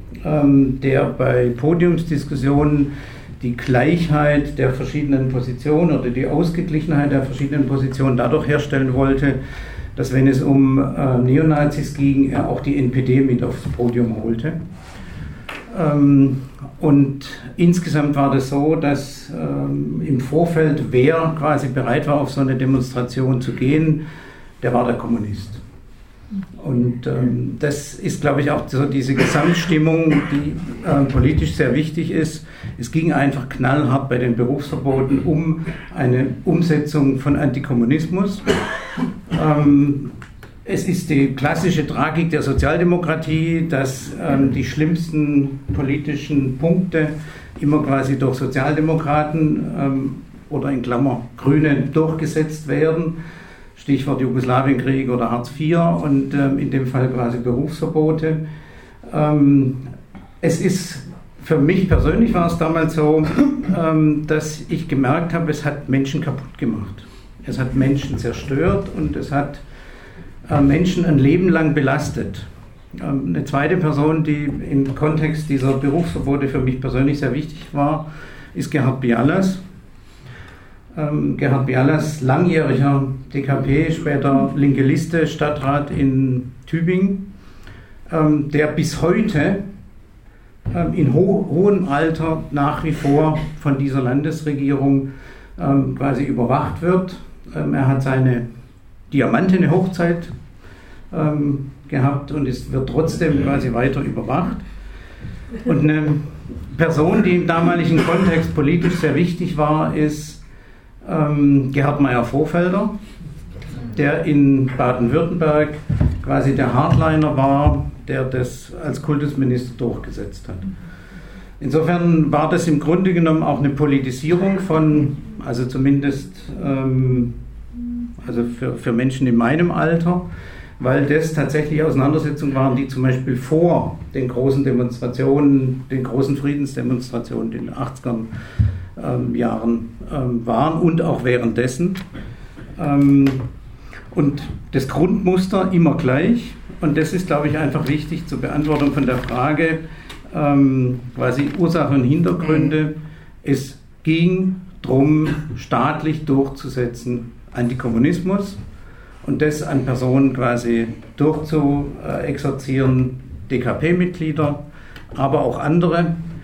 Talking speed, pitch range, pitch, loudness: 115 wpm, 130-155 Hz, 140 Hz, -18 LUFS